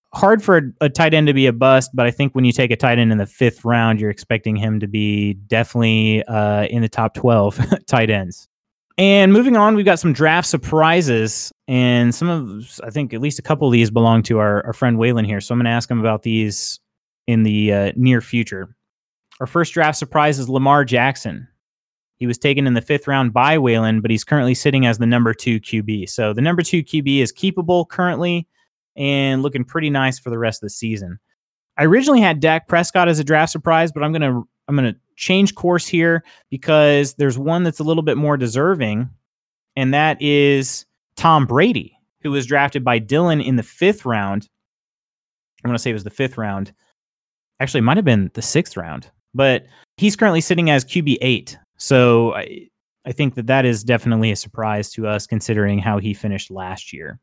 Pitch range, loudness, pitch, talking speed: 110-150 Hz, -17 LUFS, 125 Hz, 210 wpm